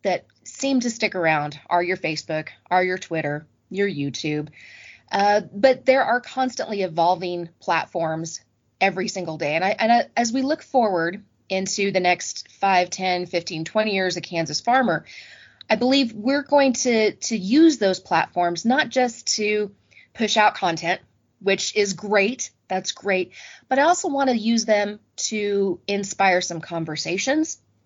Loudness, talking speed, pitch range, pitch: -22 LUFS, 155 wpm, 175-235 Hz, 195 Hz